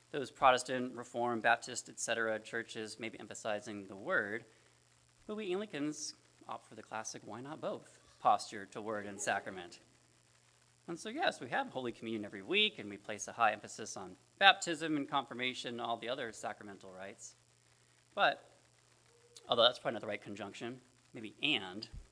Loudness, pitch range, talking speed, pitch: -36 LUFS, 100-130 Hz, 165 wpm, 115 Hz